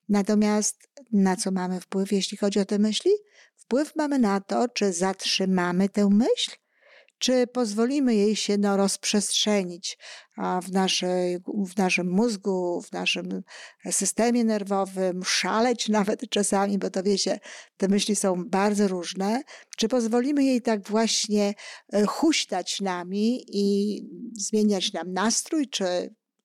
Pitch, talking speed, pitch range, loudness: 205 Hz, 125 wpm, 190-225 Hz, -25 LUFS